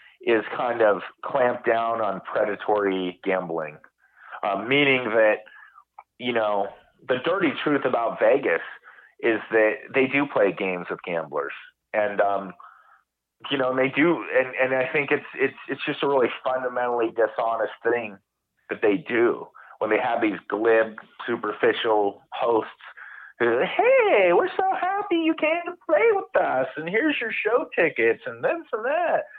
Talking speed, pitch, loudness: 155 wpm, 130 Hz, -23 LUFS